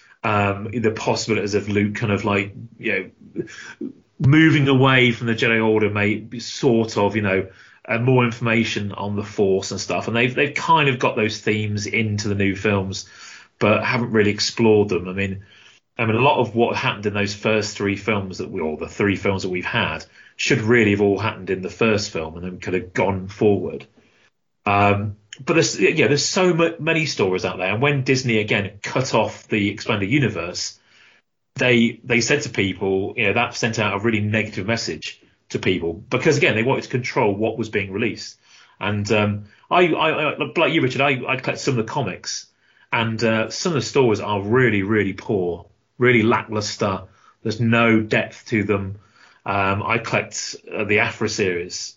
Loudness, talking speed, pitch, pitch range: -20 LUFS, 195 wpm, 105 Hz, 100-115 Hz